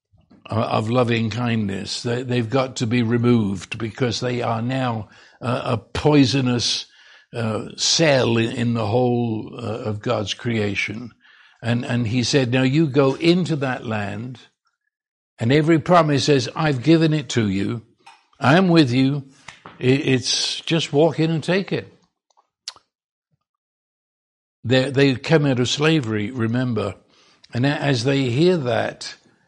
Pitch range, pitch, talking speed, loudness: 115-145 Hz, 125 Hz, 125 wpm, -20 LUFS